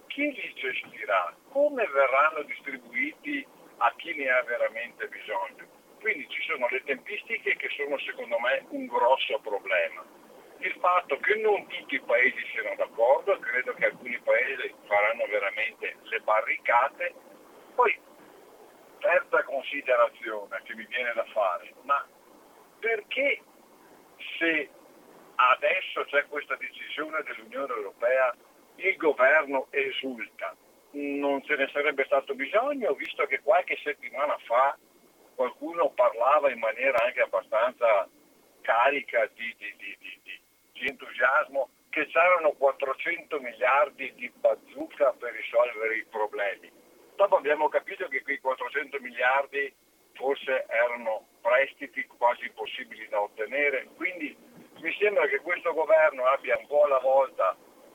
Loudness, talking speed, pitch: -27 LUFS, 125 wpm, 290 Hz